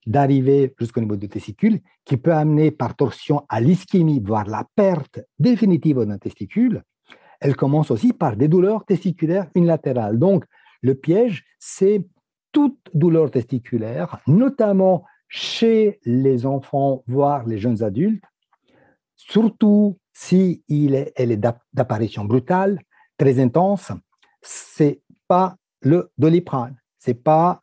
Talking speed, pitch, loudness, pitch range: 125 wpm, 155 Hz, -19 LUFS, 130-190 Hz